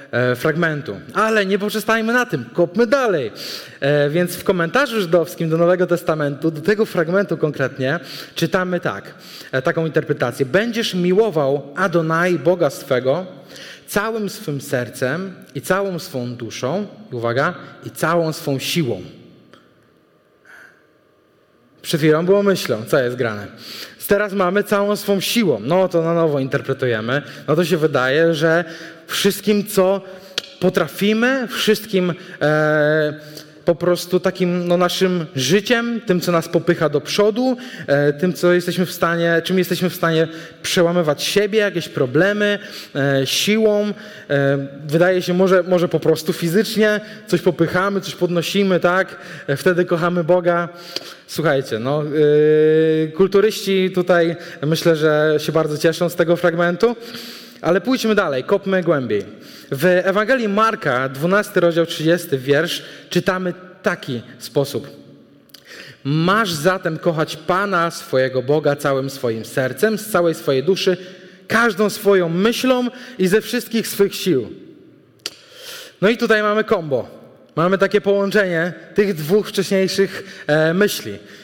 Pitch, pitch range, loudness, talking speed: 175 Hz, 155-200 Hz, -18 LUFS, 125 wpm